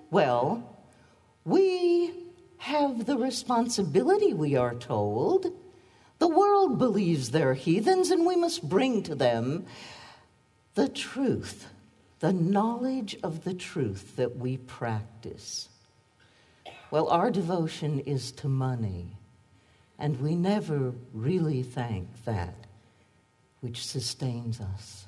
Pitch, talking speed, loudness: 145 Hz, 105 wpm, -28 LUFS